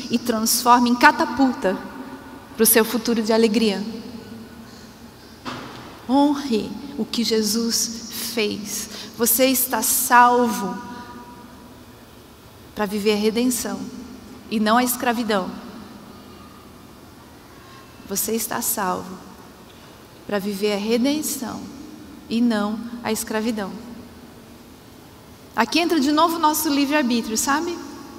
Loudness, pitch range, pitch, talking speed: -20 LUFS, 220-255 Hz, 235 Hz, 95 wpm